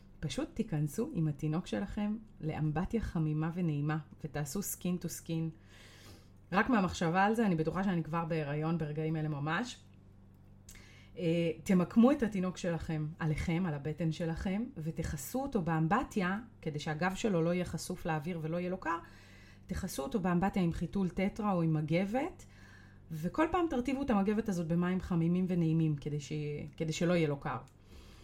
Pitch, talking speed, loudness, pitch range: 165 Hz, 145 wpm, -34 LUFS, 155-190 Hz